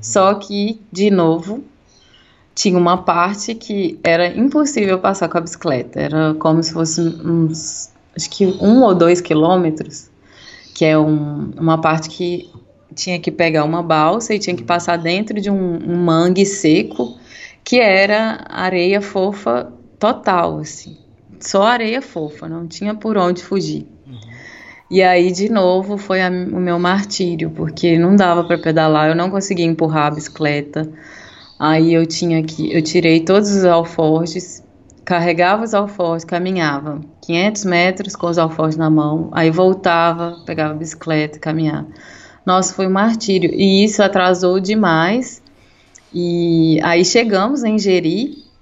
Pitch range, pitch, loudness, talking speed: 160-195 Hz, 175 Hz, -15 LUFS, 150 wpm